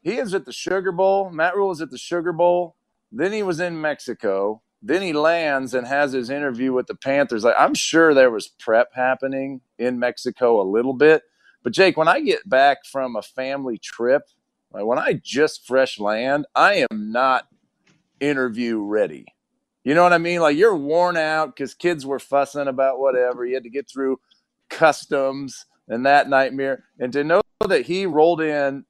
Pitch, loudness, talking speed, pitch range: 140 Hz, -20 LUFS, 190 wpm, 130-175 Hz